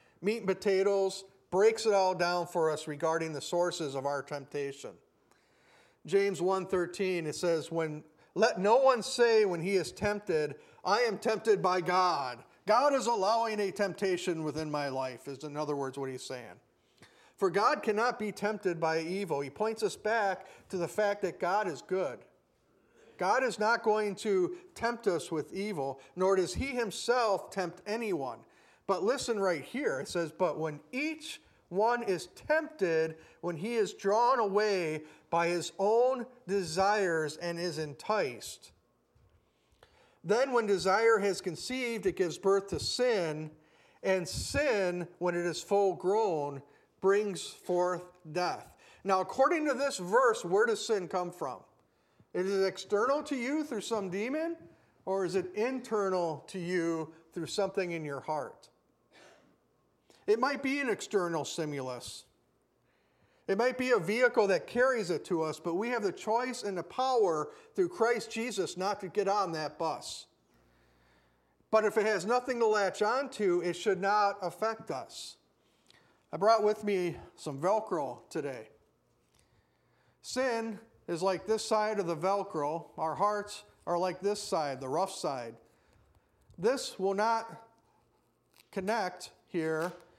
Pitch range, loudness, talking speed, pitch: 170-225 Hz, -32 LUFS, 150 wpm, 195 Hz